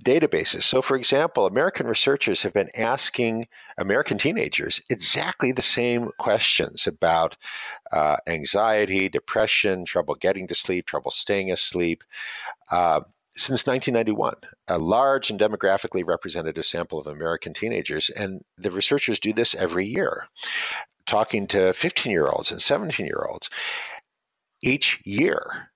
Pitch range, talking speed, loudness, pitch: 95-120 Hz, 130 wpm, -23 LUFS, 105 Hz